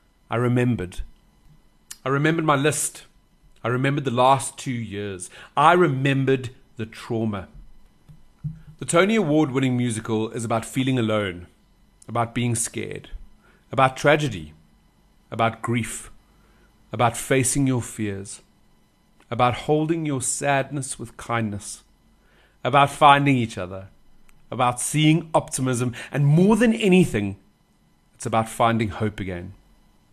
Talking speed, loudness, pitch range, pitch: 115 wpm, -22 LUFS, 110-140 Hz, 125 Hz